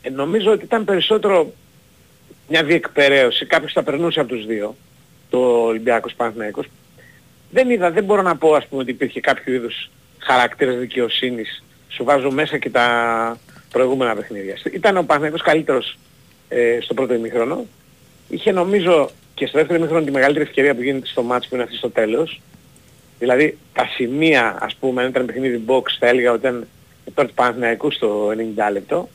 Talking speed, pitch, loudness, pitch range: 165 wpm, 130 Hz, -18 LUFS, 120-160 Hz